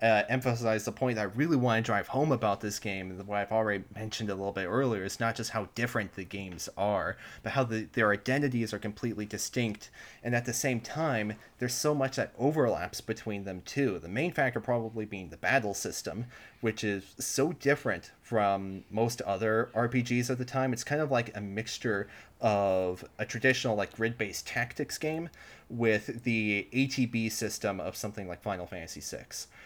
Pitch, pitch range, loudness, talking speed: 110 Hz, 105-125 Hz, -31 LUFS, 190 wpm